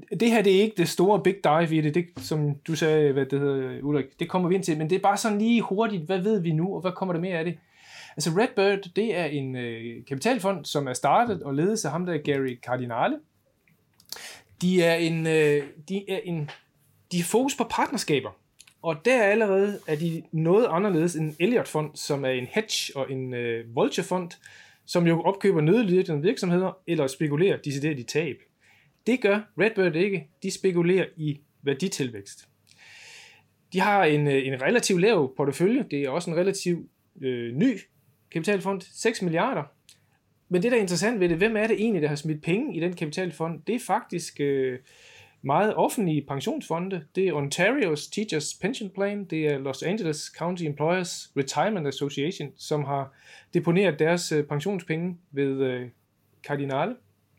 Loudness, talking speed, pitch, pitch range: -25 LUFS, 185 wpm, 165 Hz, 145-195 Hz